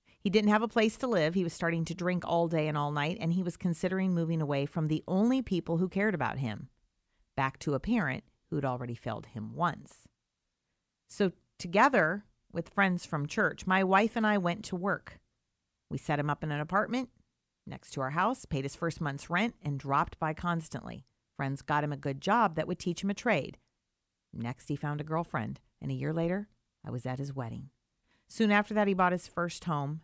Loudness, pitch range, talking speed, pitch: -31 LUFS, 145-195 Hz, 215 wpm, 170 Hz